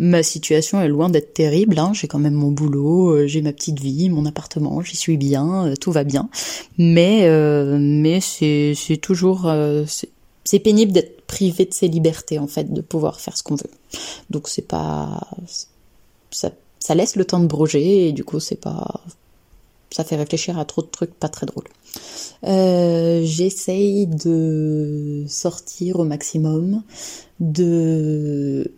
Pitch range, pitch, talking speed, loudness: 150-180 Hz, 160 Hz, 165 wpm, -19 LUFS